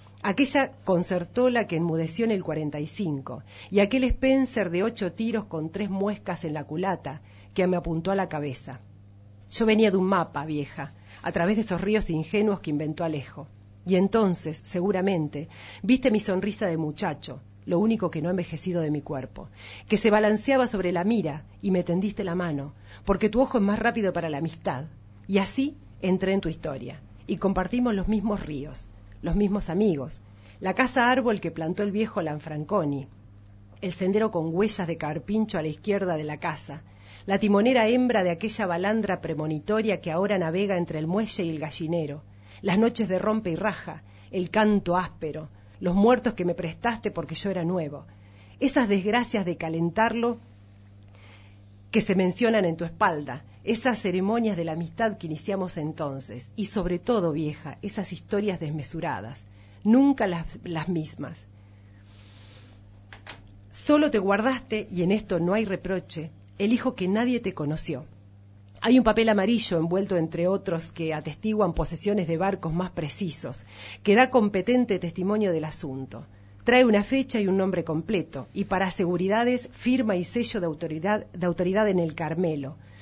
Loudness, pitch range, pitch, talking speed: -26 LUFS, 150-210 Hz, 175 Hz, 165 wpm